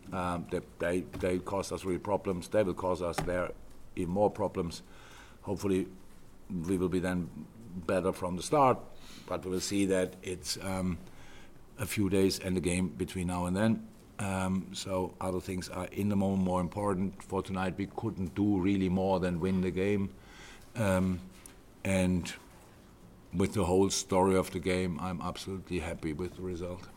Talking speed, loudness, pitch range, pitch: 175 wpm, -32 LUFS, 90-95 Hz, 95 Hz